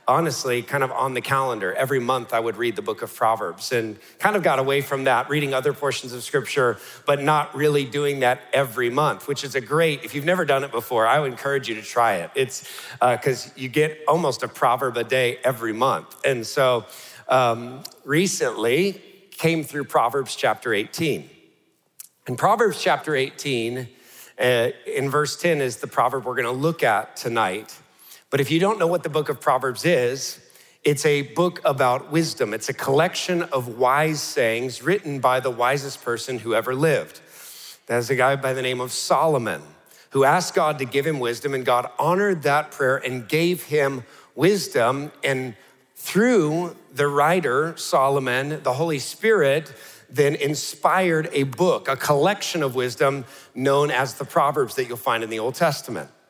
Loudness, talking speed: -22 LUFS, 180 wpm